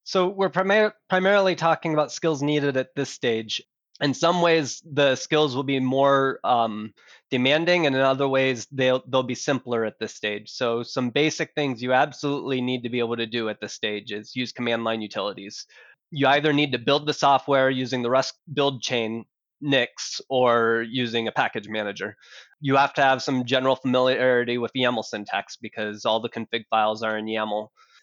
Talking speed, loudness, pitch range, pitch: 190 wpm, -23 LUFS, 115-145 Hz, 130 Hz